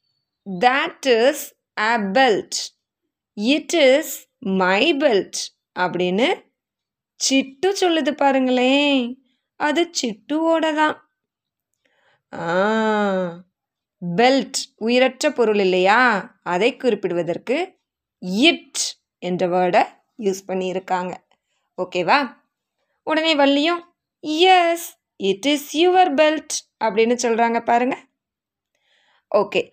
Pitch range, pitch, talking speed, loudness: 195-305 Hz, 255 Hz, 75 wpm, -19 LUFS